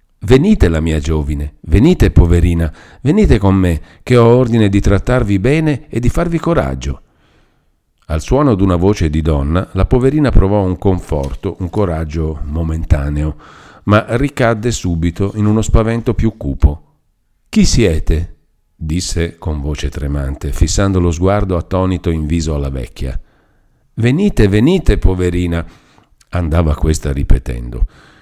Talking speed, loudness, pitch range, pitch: 130 wpm, -14 LUFS, 80-105 Hz, 90 Hz